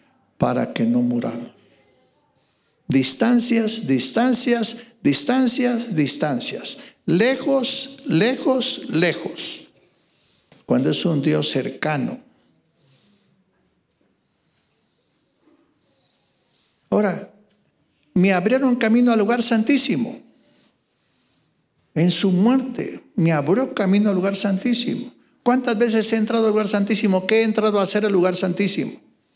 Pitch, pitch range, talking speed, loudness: 230 Hz, 195-250 Hz, 95 wpm, -19 LUFS